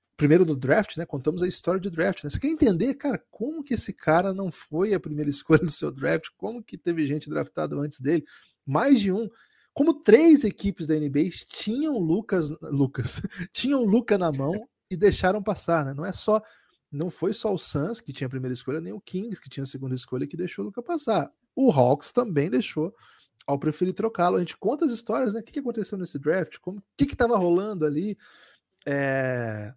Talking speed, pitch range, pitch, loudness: 210 wpm, 150-215 Hz, 180 Hz, -25 LUFS